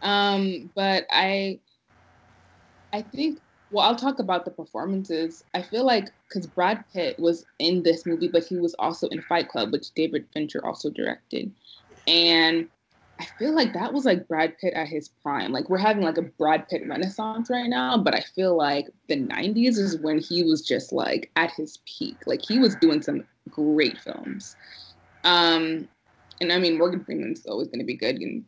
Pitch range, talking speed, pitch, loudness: 160-215 Hz, 190 wpm, 175 Hz, -24 LUFS